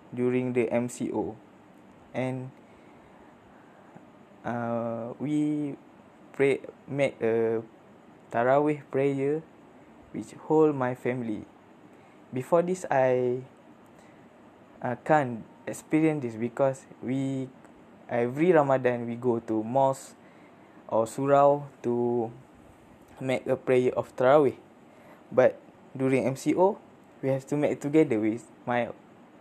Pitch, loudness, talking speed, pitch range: 130 Hz, -27 LUFS, 95 wpm, 120-140 Hz